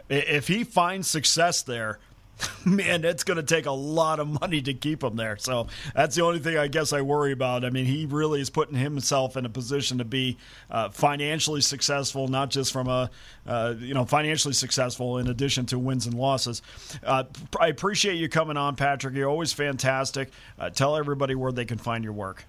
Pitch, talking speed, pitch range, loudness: 135 Hz, 205 wpm, 125-155 Hz, -26 LUFS